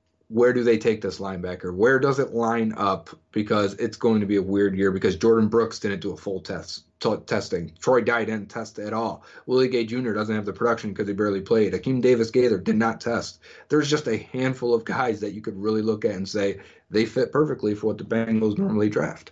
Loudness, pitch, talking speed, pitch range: -24 LUFS, 110 Hz, 235 wpm, 100-120 Hz